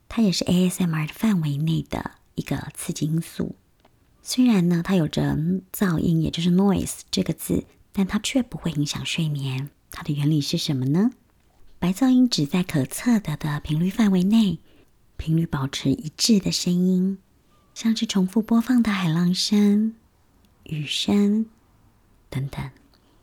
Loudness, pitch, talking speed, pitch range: -23 LUFS, 175 Hz, 235 characters per minute, 150-205 Hz